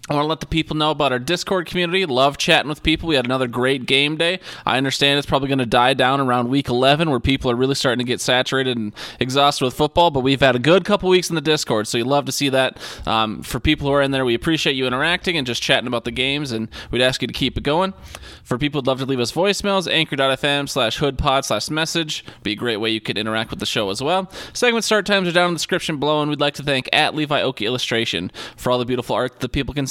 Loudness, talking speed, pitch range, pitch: -19 LUFS, 275 wpm, 125-155 Hz, 140 Hz